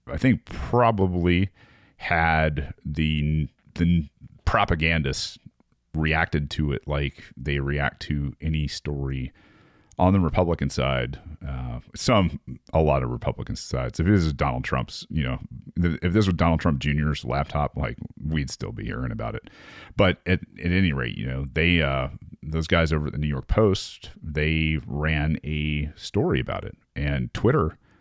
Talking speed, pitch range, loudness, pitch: 160 wpm, 70-85 Hz, -25 LUFS, 75 Hz